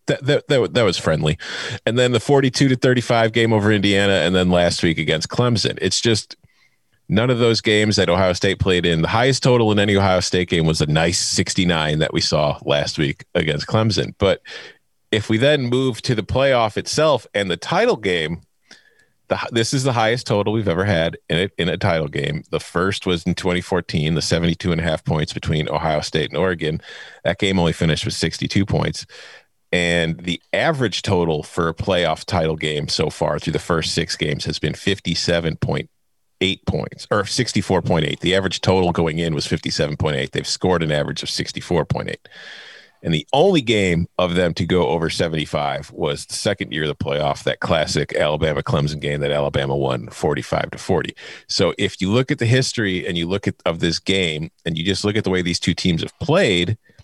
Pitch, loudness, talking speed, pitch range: 95 Hz, -19 LUFS, 200 wpm, 85-110 Hz